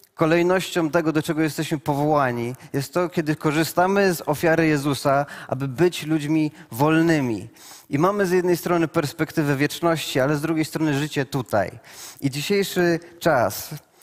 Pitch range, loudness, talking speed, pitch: 145-170 Hz, -22 LUFS, 140 wpm, 160 Hz